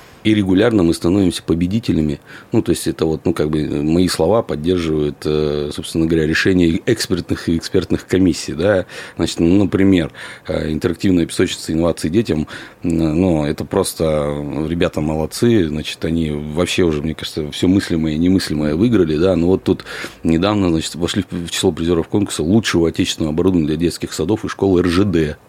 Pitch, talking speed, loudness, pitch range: 85 Hz, 160 wpm, -17 LUFS, 80-95 Hz